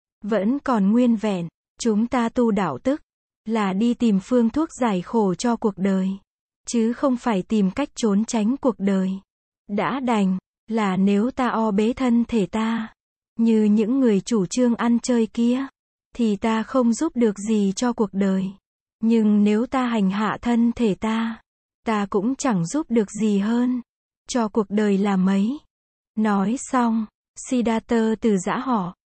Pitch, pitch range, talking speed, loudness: 225 Hz, 205-240 Hz, 165 wpm, -22 LUFS